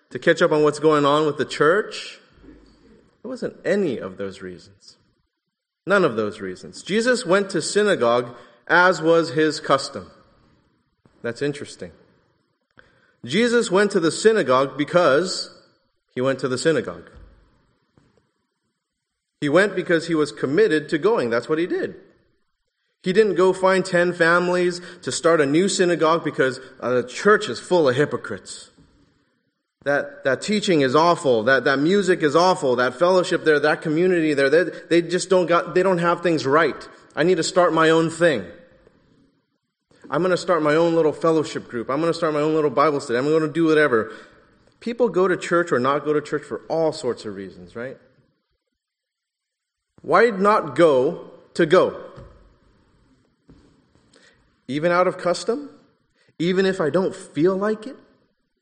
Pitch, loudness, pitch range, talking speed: 165 Hz, -20 LUFS, 140-185 Hz, 160 wpm